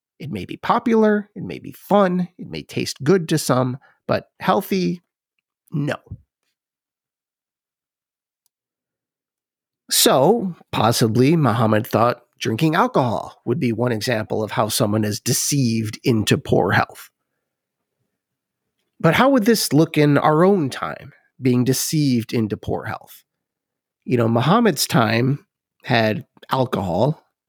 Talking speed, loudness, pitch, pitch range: 120 wpm, -19 LUFS, 130 Hz, 115-175 Hz